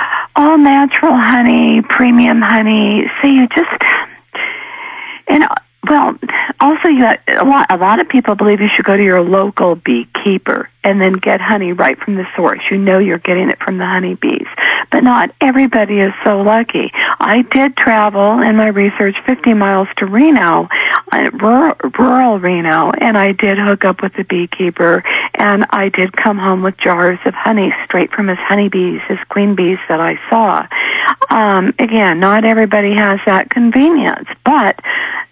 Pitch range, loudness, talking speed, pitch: 195-250 Hz, -11 LUFS, 165 wpm, 210 Hz